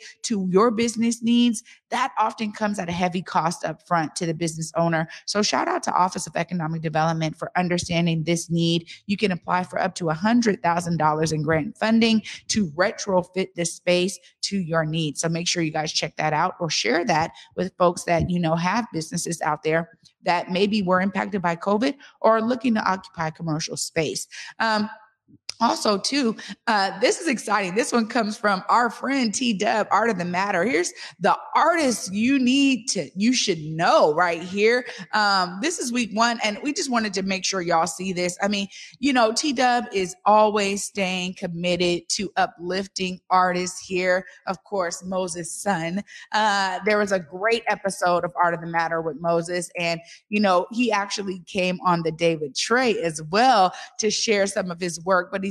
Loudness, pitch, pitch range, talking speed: -23 LUFS, 185 Hz, 170-220 Hz, 190 wpm